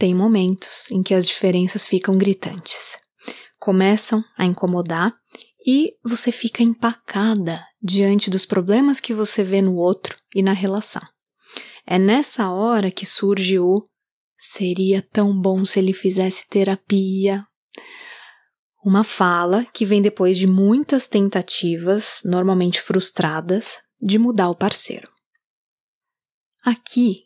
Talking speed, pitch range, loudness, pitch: 120 wpm, 190-220 Hz, -19 LUFS, 195 Hz